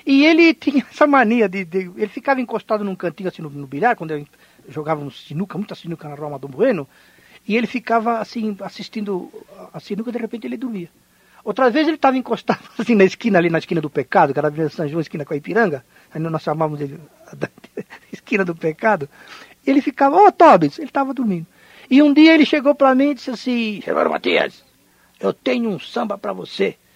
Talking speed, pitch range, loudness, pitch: 220 wpm, 165-265 Hz, -18 LUFS, 215 Hz